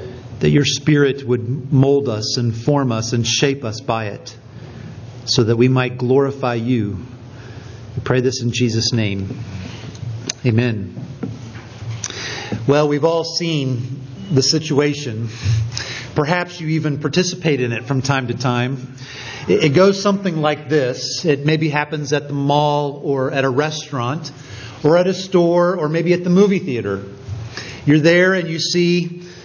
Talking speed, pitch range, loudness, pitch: 150 wpm, 120-150 Hz, -18 LUFS, 130 Hz